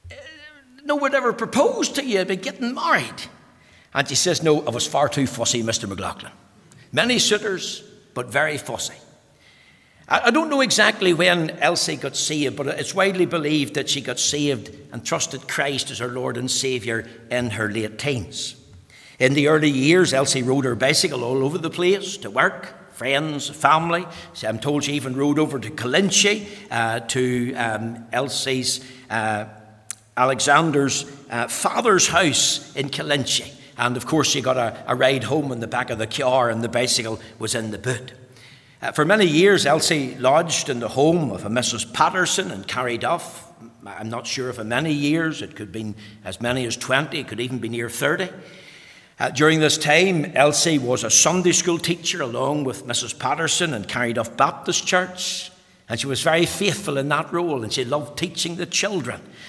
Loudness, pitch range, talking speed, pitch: -21 LUFS, 120-170 Hz, 180 wpm, 140 Hz